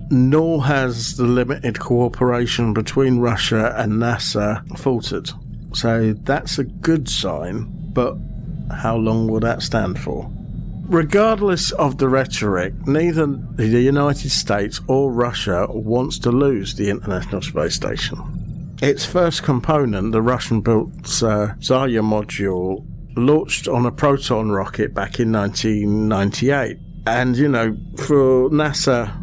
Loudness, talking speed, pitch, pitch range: -19 LUFS, 120 wpm, 125 Hz, 110-145 Hz